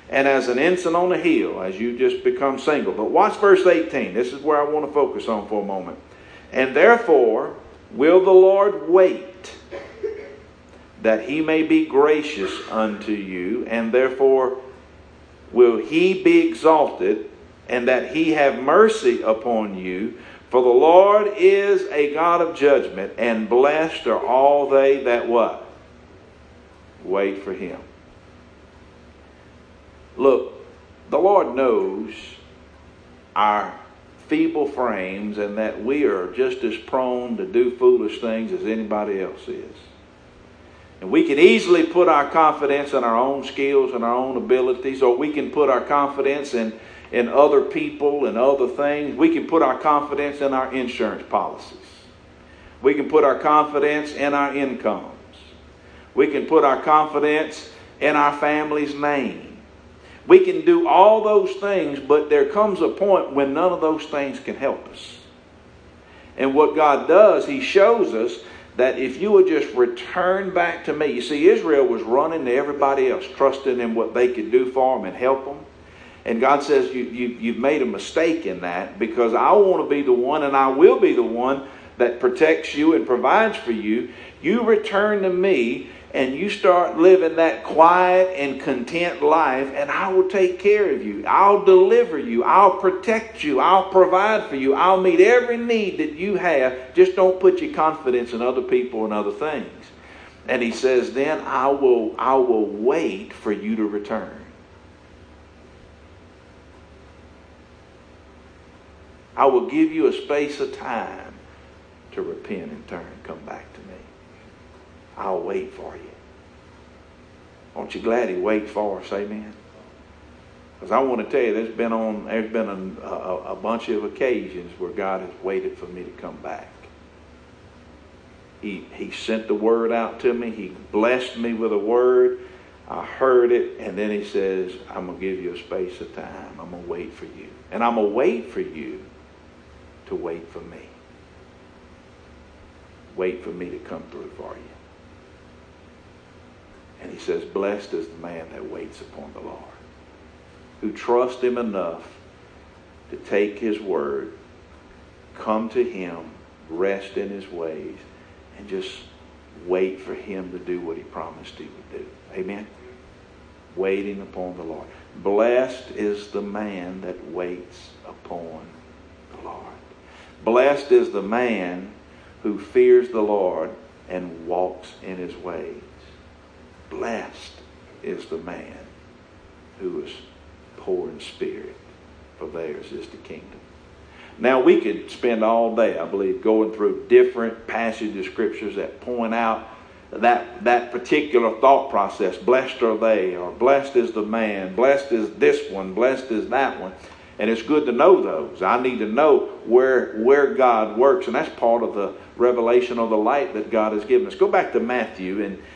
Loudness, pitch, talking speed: -19 LUFS, 125 Hz, 160 wpm